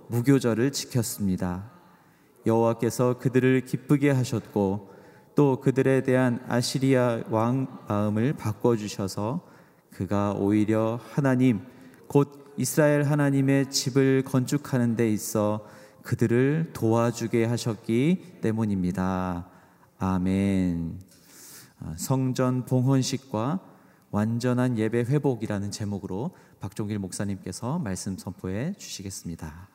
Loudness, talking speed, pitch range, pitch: -26 LUFS, 250 characters per minute, 100-130 Hz, 115 Hz